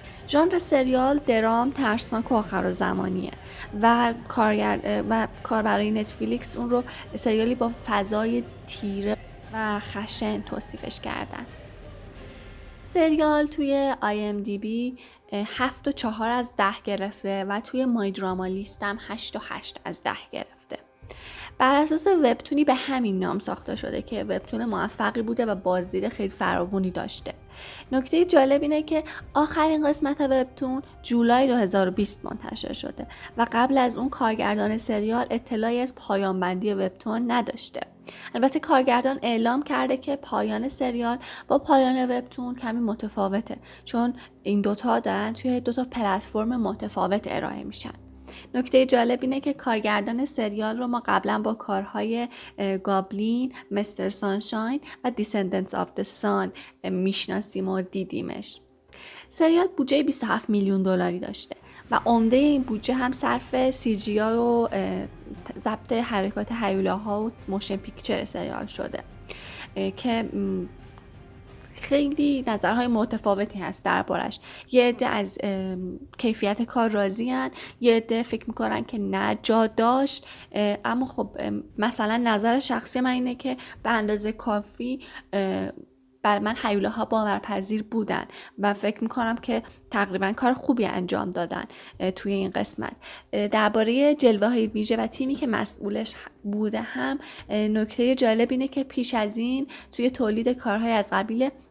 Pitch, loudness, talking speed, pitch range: 225 Hz, -25 LUFS, 130 wpm, 205-255 Hz